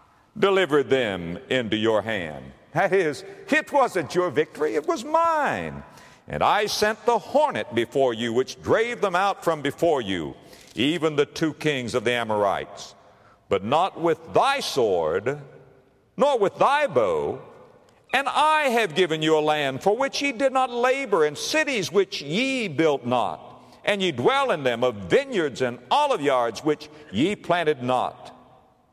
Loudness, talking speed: -23 LUFS, 160 wpm